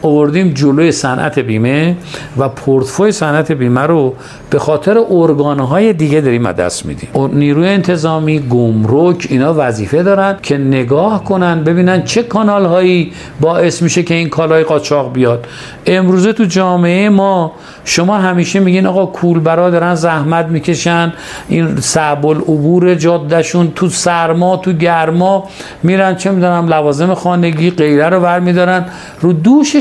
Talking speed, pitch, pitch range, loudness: 135 wpm, 170 Hz, 150-180 Hz, -11 LUFS